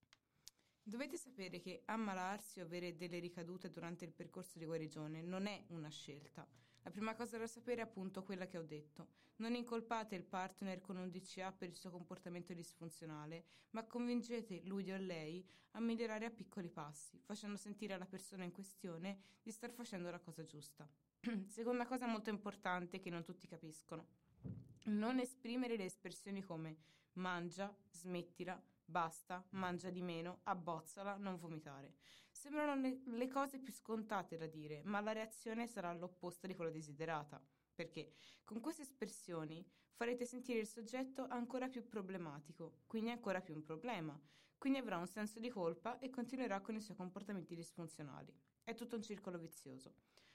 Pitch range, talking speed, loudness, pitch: 170-225 Hz, 160 wpm, -48 LUFS, 185 Hz